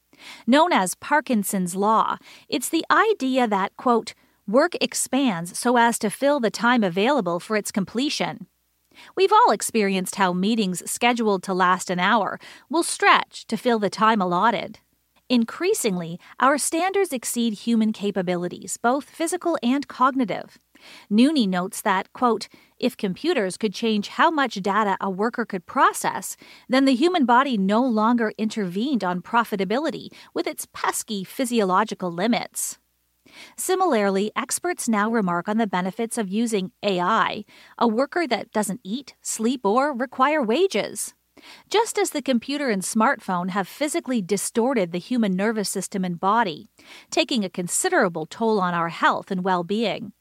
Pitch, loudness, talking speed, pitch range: 230 Hz, -22 LUFS, 145 wpm, 200-270 Hz